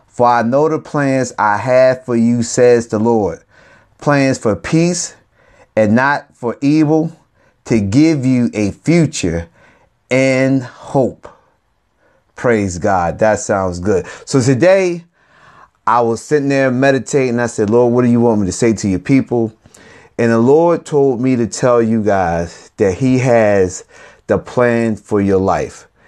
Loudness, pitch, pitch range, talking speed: -14 LUFS, 120 Hz, 110-135 Hz, 155 wpm